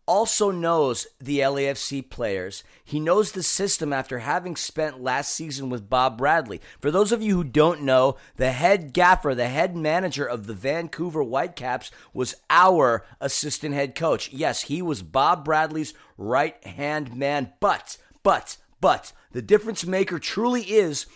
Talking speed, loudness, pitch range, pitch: 155 wpm, -23 LUFS, 135-180 Hz, 150 Hz